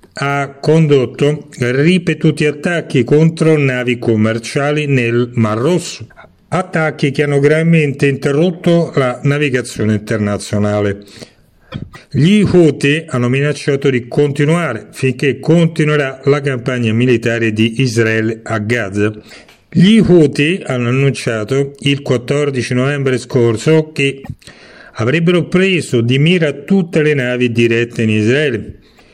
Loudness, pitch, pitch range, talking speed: -13 LUFS, 140 Hz, 120-155 Hz, 105 wpm